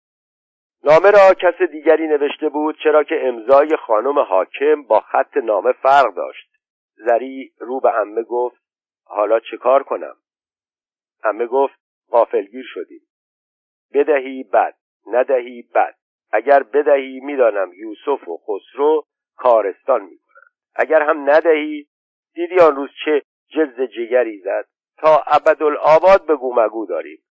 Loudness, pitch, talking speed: -16 LUFS, 155 Hz, 125 wpm